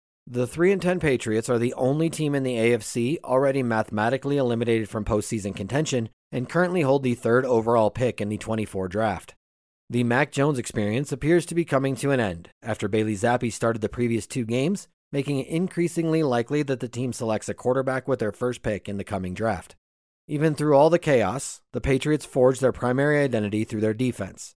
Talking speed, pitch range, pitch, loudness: 190 wpm, 110-140 Hz, 125 Hz, -24 LUFS